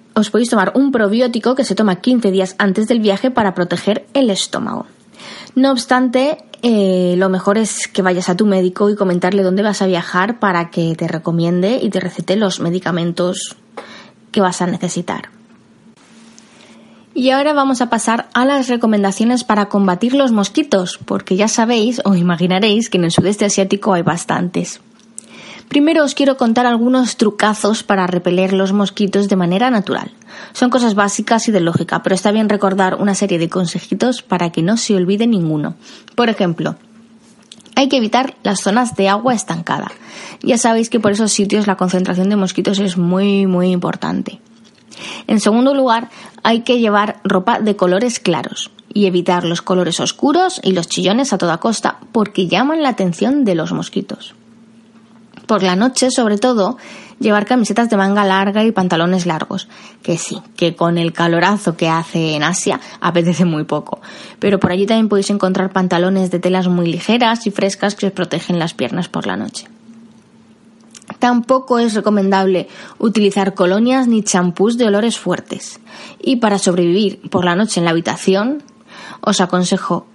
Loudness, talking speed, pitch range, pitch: -15 LUFS, 170 wpm, 185-230 Hz, 205 Hz